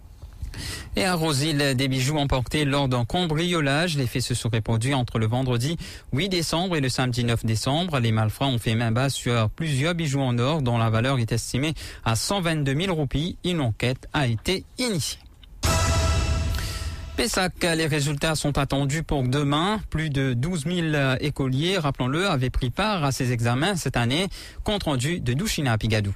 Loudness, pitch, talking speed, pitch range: -24 LUFS, 135 Hz, 175 wpm, 115-155 Hz